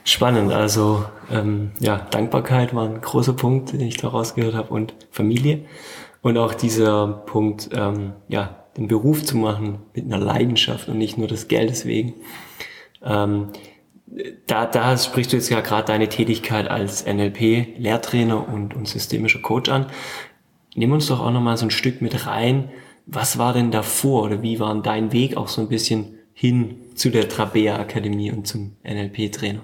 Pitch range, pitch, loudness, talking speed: 105-120 Hz, 110 Hz, -21 LUFS, 170 wpm